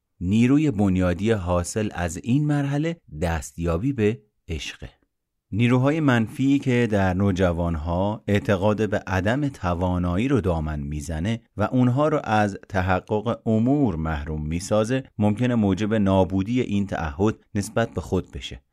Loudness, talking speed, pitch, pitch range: -23 LUFS, 120 wpm, 105 Hz, 90-120 Hz